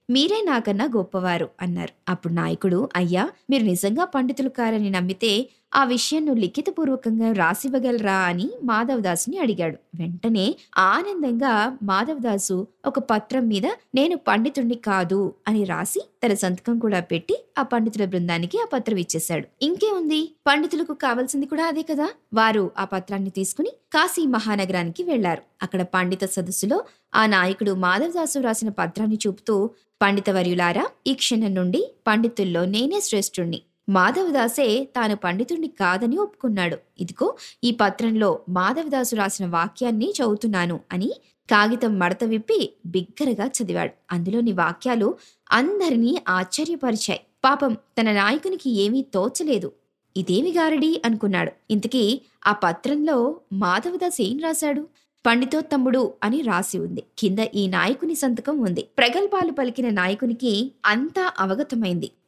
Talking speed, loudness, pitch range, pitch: 120 wpm, -22 LUFS, 190-275 Hz, 225 Hz